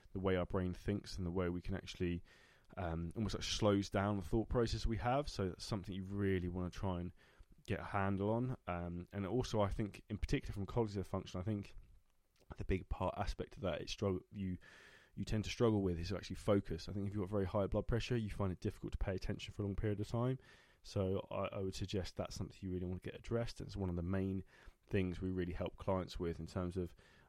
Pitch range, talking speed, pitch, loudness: 90-105 Hz, 245 wpm, 95 Hz, -41 LUFS